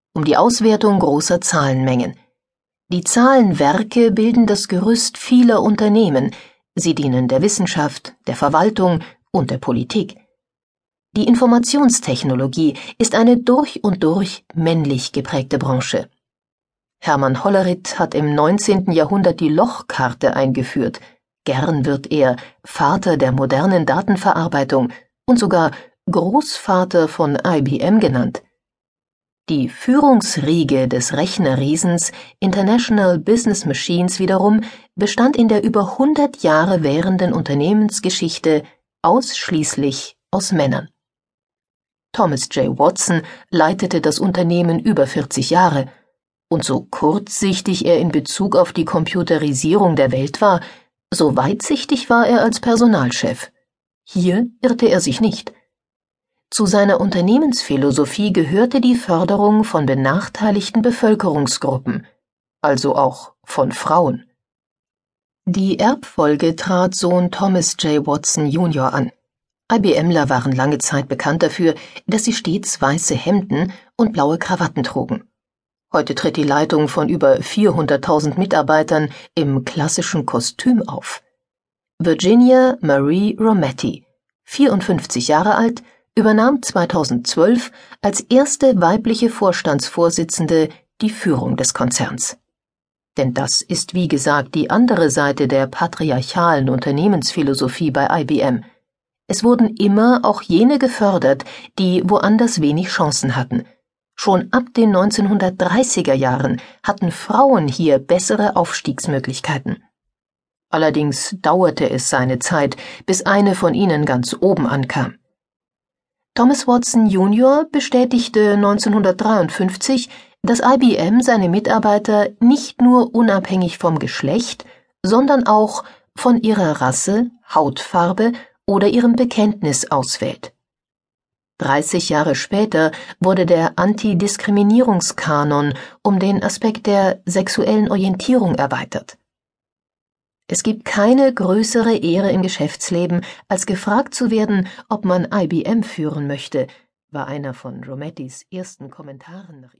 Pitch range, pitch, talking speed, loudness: 155-220 Hz, 185 Hz, 110 wpm, -16 LUFS